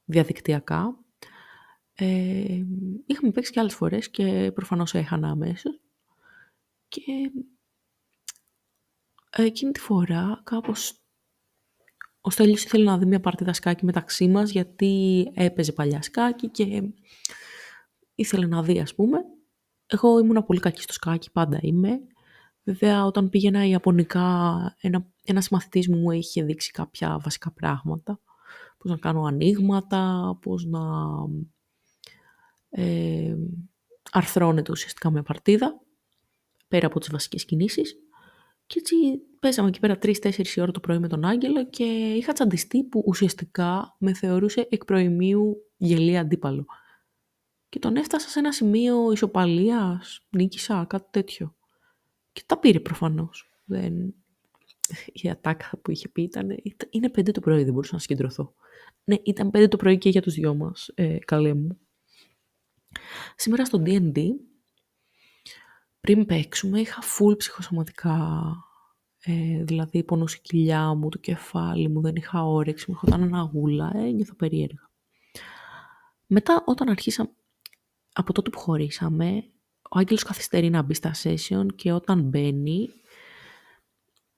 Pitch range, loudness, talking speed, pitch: 170-225 Hz, -24 LUFS, 130 wpm, 190 Hz